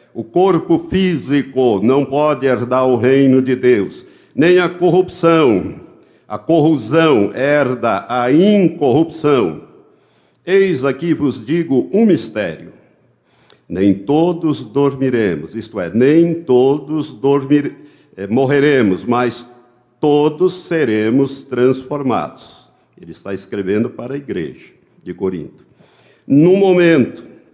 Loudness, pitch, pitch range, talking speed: -14 LUFS, 140 Hz, 125-165 Hz, 105 wpm